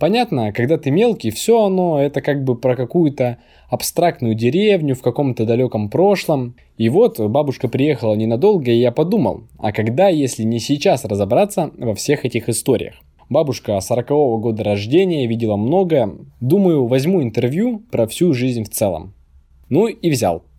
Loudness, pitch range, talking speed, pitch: -17 LUFS, 115-165 Hz, 150 wpm, 130 Hz